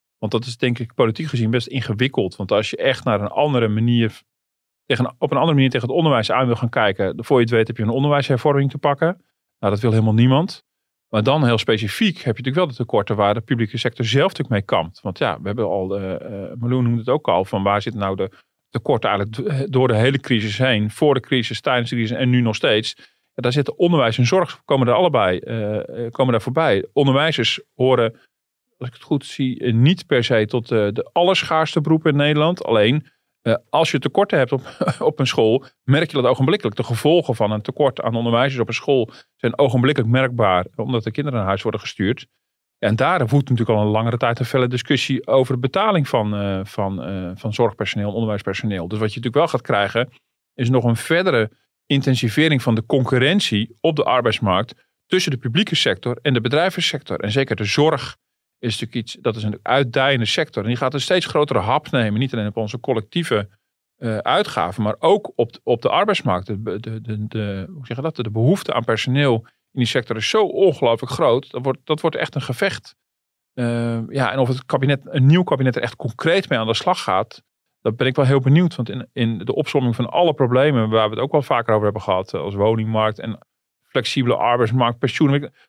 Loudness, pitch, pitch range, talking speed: -19 LUFS, 125 Hz, 110-140 Hz, 210 wpm